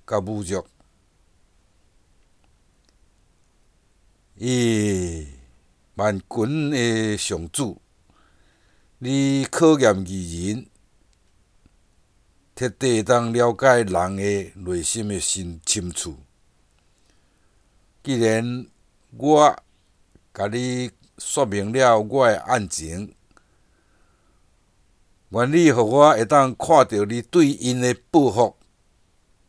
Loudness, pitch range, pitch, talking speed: -20 LUFS, 85-120 Hz, 100 Hz, 110 characters per minute